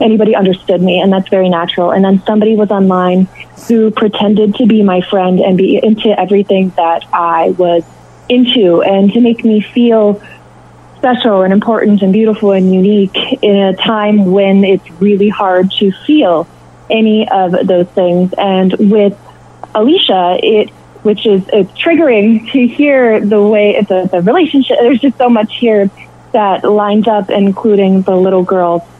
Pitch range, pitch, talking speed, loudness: 190-220 Hz, 205 Hz, 165 wpm, -10 LUFS